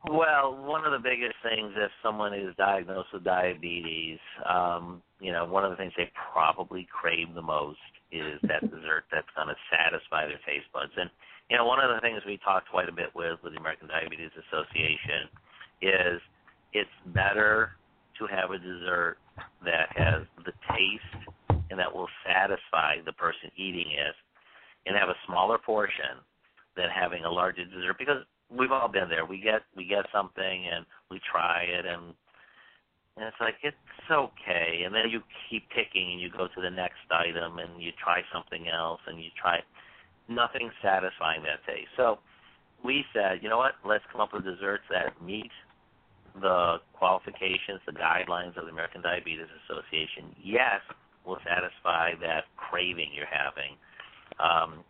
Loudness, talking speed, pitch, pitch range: -29 LUFS, 170 wpm, 90 Hz, 85-105 Hz